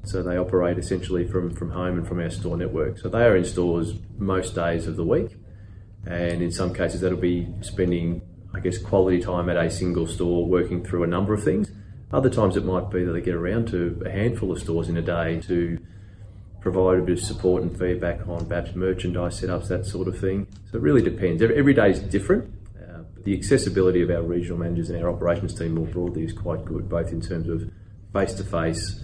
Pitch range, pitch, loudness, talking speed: 85-100 Hz, 90 Hz, -24 LUFS, 225 wpm